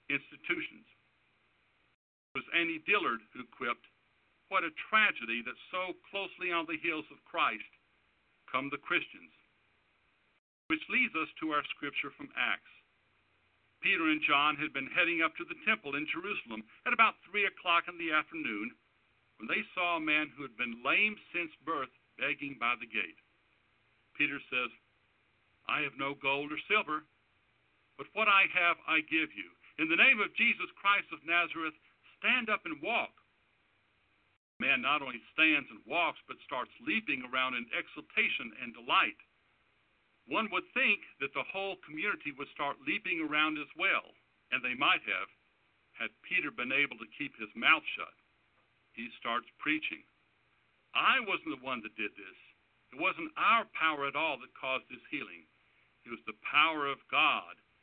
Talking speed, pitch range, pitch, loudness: 165 wpm, 130-185 Hz, 155 Hz, -32 LUFS